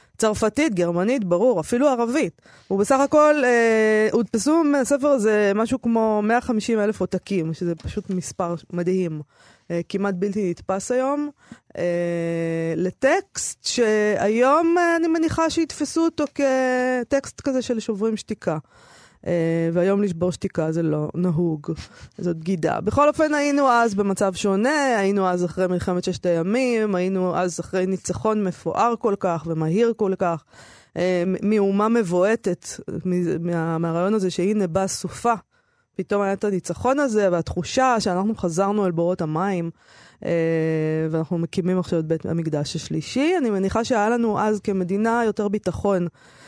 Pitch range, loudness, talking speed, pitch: 175-235 Hz, -22 LUFS, 130 wpm, 200 Hz